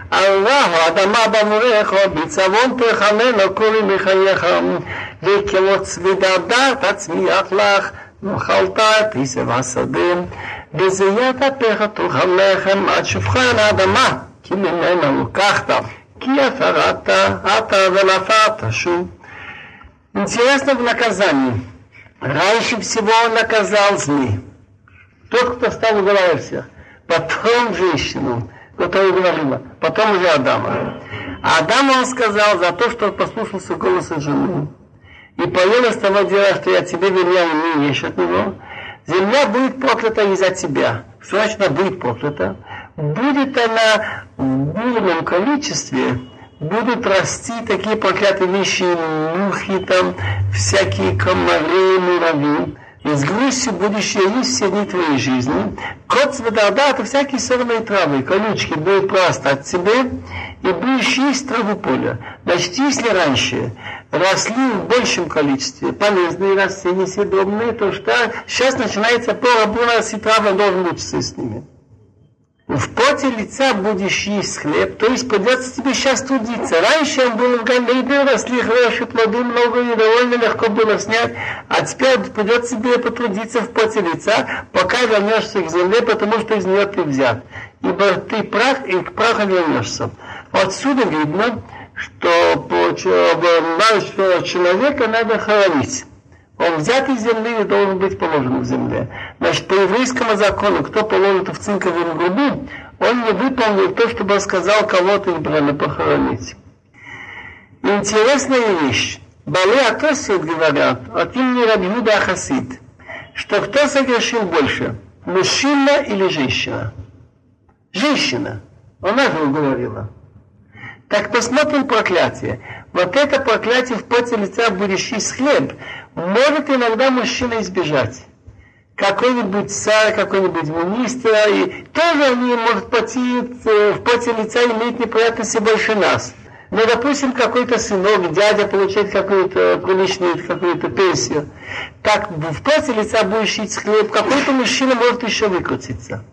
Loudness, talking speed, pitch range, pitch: -16 LUFS, 130 wpm, 175-235 Hz, 205 Hz